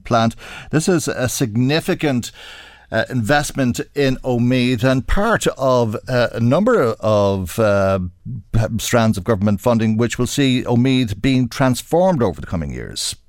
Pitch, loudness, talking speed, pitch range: 120 Hz, -18 LUFS, 140 wpm, 110-130 Hz